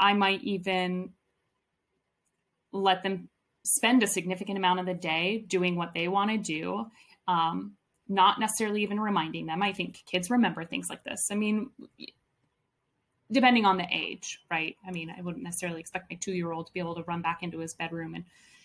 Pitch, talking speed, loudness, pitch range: 185 Hz, 185 wpm, -29 LUFS, 170-205 Hz